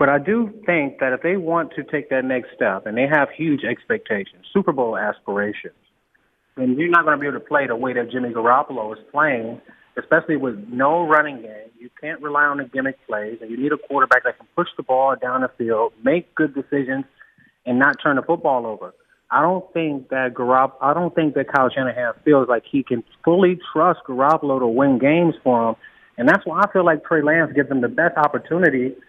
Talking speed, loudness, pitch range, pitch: 220 wpm, -19 LUFS, 130-165 Hz, 145 Hz